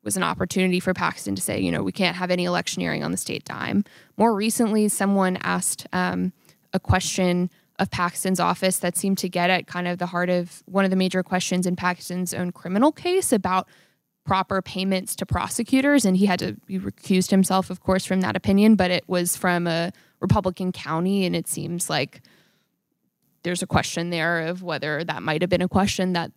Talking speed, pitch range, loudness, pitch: 205 wpm, 175-190 Hz, -23 LUFS, 180 Hz